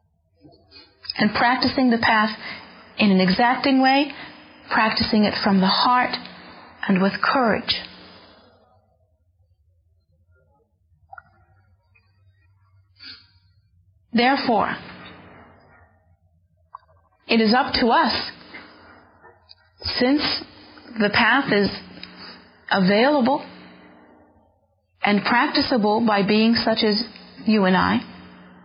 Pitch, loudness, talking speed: 195 Hz, -19 LUFS, 75 wpm